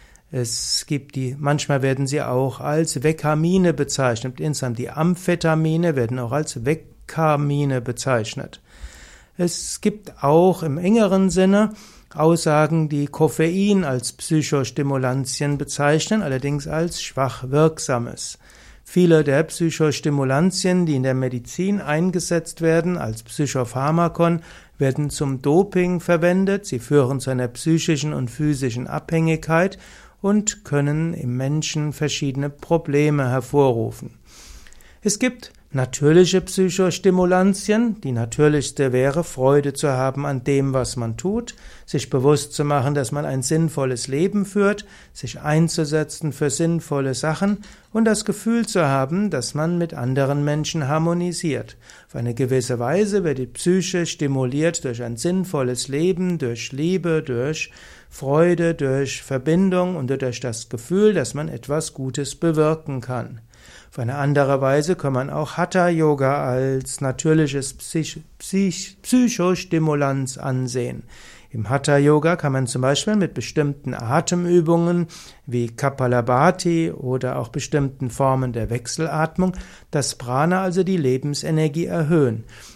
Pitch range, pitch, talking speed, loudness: 130-170 Hz, 150 Hz, 125 wpm, -21 LUFS